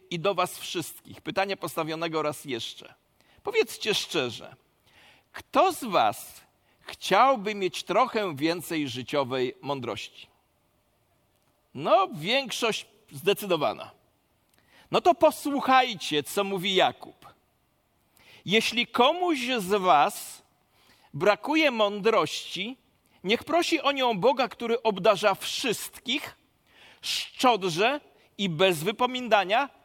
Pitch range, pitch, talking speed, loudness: 180-260 Hz, 215 Hz, 90 wpm, -26 LUFS